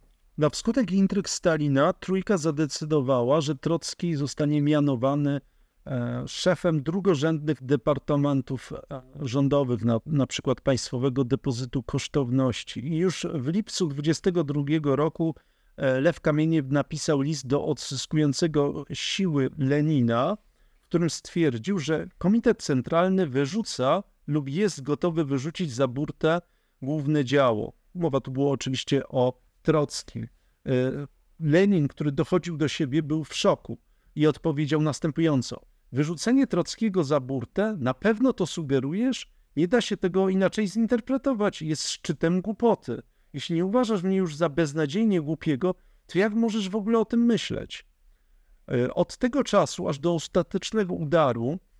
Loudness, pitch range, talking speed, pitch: -26 LUFS, 140-185 Hz, 120 wpm, 155 Hz